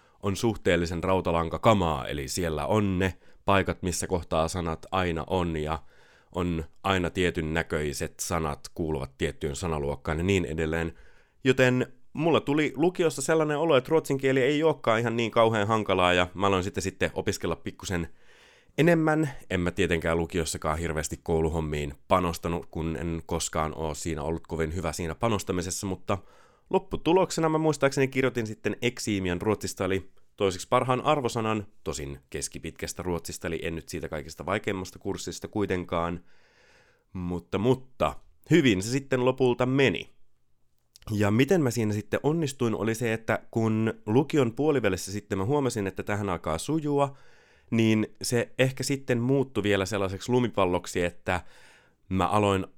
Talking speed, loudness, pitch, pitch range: 140 wpm, -27 LUFS, 95 Hz, 85-120 Hz